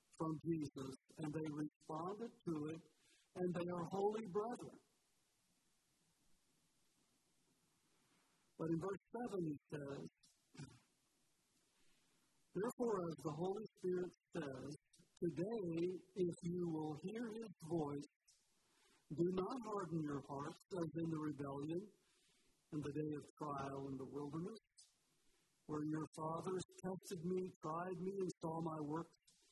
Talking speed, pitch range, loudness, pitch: 120 wpm, 150-185 Hz, -46 LUFS, 165 Hz